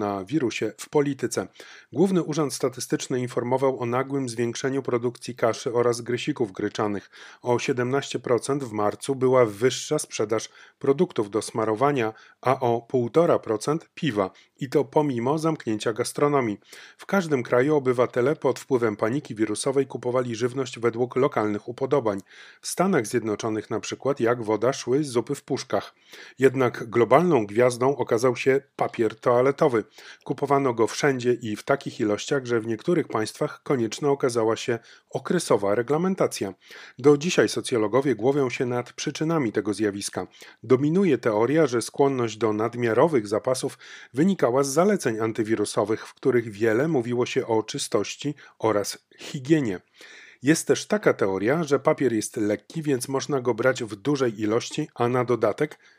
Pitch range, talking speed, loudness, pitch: 115-140 Hz, 140 wpm, -24 LUFS, 125 Hz